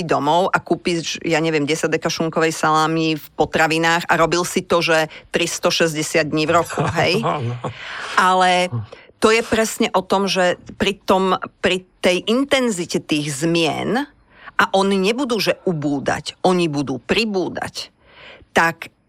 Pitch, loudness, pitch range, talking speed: 175 Hz, -18 LUFS, 160-195 Hz, 140 wpm